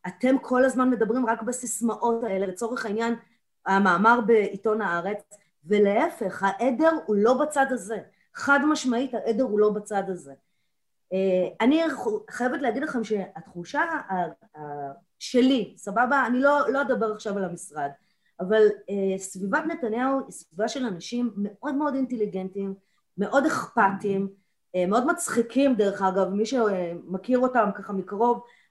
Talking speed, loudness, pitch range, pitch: 125 wpm, -25 LUFS, 195-255 Hz, 220 Hz